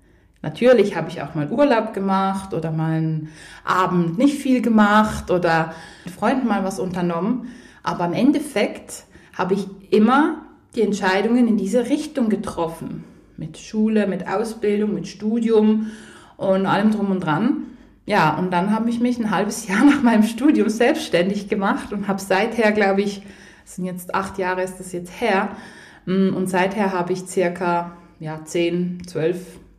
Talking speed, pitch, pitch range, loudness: 160 wpm, 195 Hz, 180-220 Hz, -20 LUFS